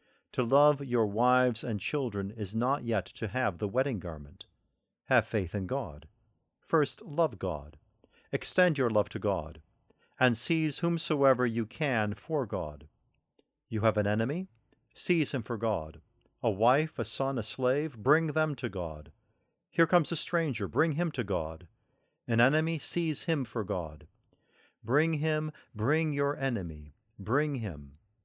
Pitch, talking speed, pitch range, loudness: 120 Hz, 155 wpm, 105-150 Hz, -30 LUFS